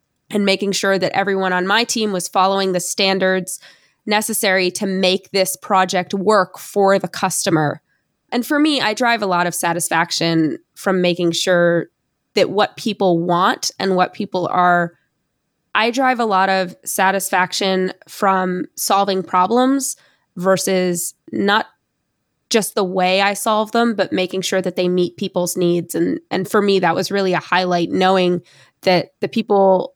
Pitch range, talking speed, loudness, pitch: 180-205 Hz, 160 wpm, -17 LUFS, 190 Hz